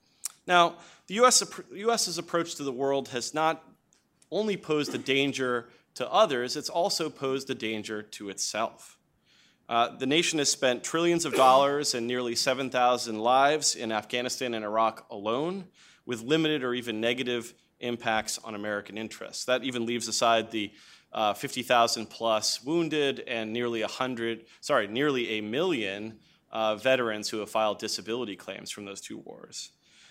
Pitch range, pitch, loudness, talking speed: 110-145 Hz, 125 Hz, -28 LUFS, 150 wpm